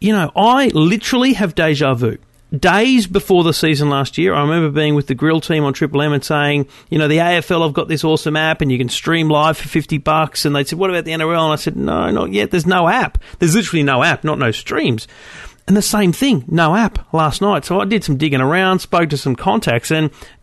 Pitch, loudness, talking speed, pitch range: 160 Hz, -15 LUFS, 245 wpm, 150-185 Hz